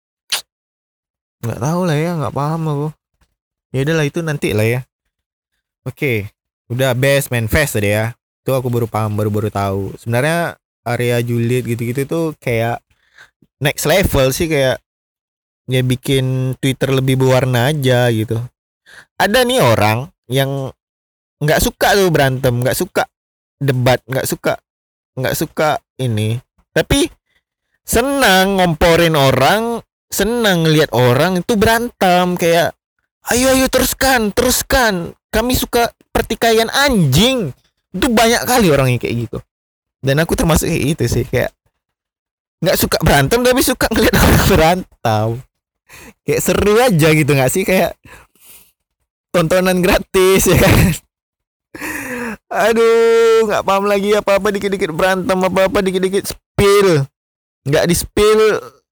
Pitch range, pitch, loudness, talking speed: 125-205 Hz, 155 Hz, -15 LUFS, 130 wpm